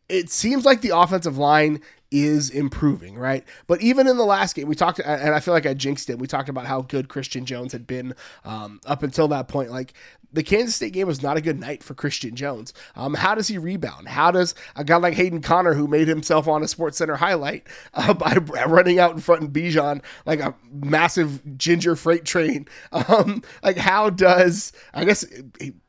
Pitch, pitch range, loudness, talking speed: 155 Hz, 140-175 Hz, -21 LUFS, 215 wpm